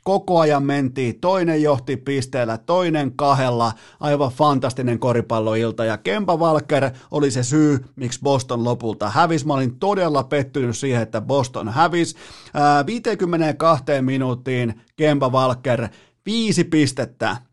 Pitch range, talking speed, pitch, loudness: 125-155 Hz, 120 wpm, 140 Hz, -20 LUFS